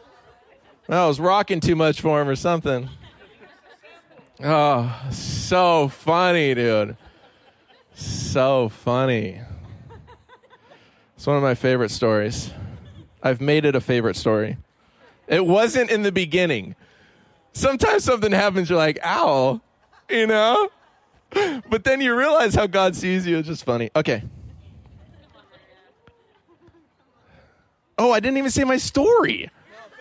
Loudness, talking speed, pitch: -20 LUFS, 120 wpm, 150 Hz